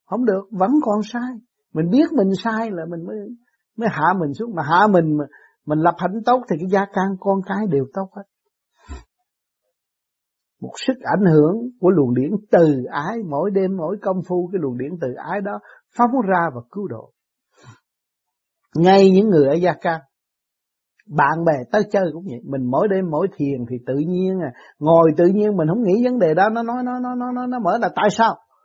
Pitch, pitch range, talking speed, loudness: 195 Hz, 165-225 Hz, 205 wpm, -19 LUFS